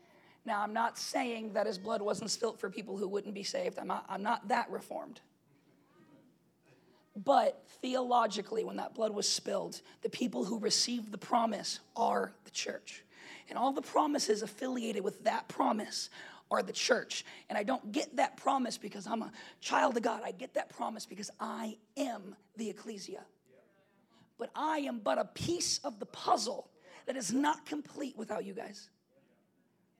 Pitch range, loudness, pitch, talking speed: 210-260 Hz, -35 LUFS, 225 Hz, 170 wpm